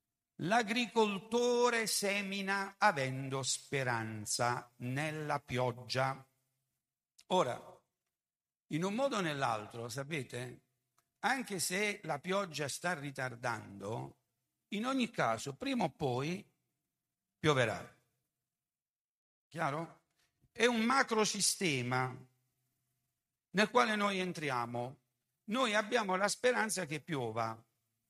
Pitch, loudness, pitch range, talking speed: 145 Hz, -35 LUFS, 125-205 Hz, 85 wpm